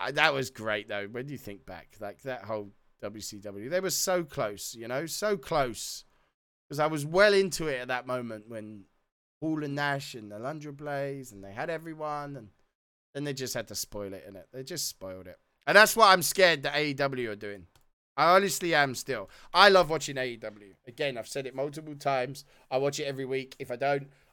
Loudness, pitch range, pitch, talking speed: -28 LUFS, 110-150 Hz, 135 Hz, 210 wpm